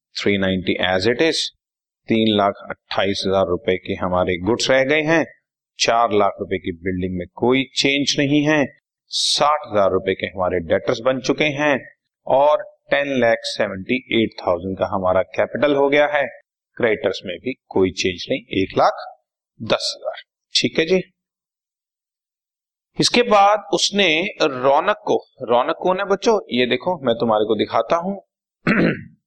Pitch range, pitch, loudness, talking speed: 95-155 Hz, 125 Hz, -19 LUFS, 155 wpm